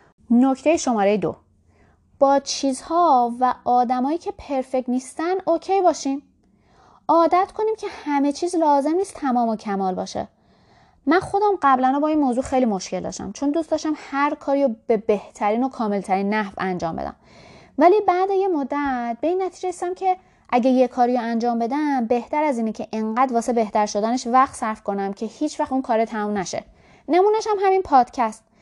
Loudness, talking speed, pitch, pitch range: -21 LUFS, 170 wpm, 265 Hz, 225-320 Hz